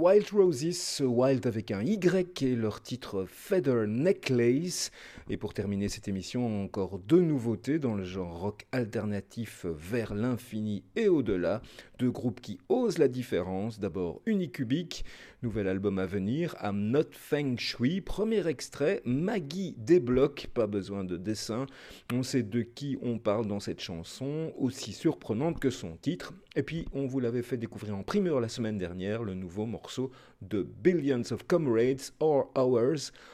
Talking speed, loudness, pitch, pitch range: 160 wpm, -31 LUFS, 120 Hz, 105-140 Hz